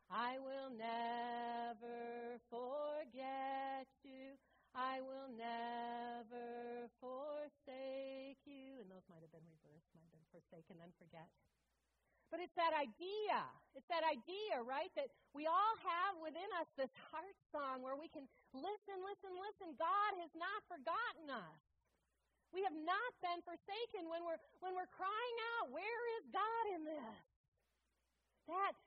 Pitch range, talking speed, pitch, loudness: 240-355 Hz, 140 wpm, 275 Hz, -46 LUFS